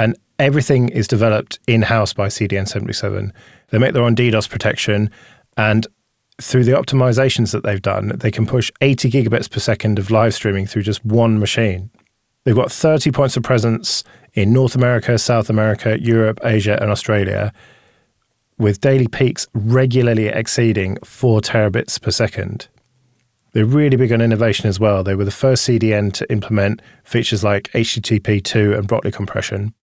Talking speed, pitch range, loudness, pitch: 160 wpm, 105-120 Hz, -16 LUFS, 115 Hz